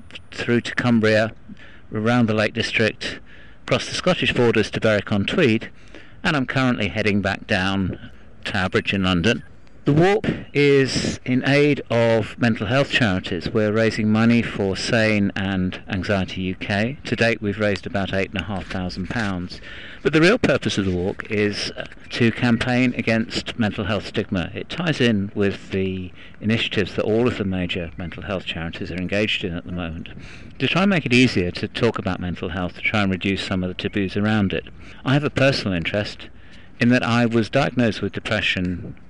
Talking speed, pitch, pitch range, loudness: 180 wpm, 105 Hz, 95-115 Hz, -21 LUFS